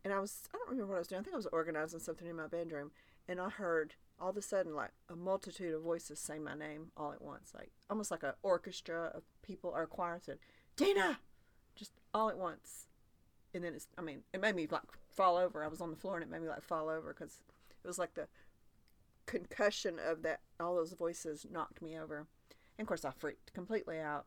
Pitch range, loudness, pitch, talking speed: 155-190 Hz, -41 LUFS, 170 Hz, 240 wpm